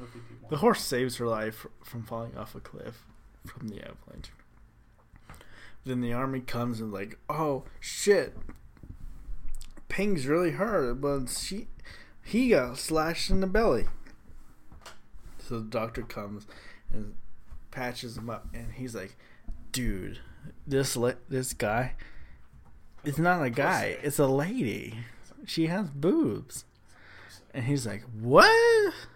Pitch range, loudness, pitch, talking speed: 115-150 Hz, -28 LUFS, 125 Hz, 130 wpm